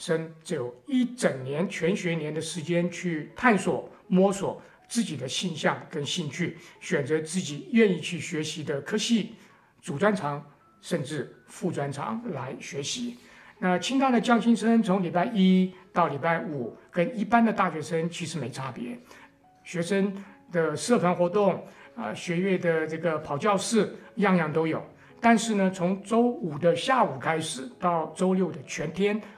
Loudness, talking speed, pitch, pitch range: -27 LUFS, 230 characters per minute, 175 Hz, 160-200 Hz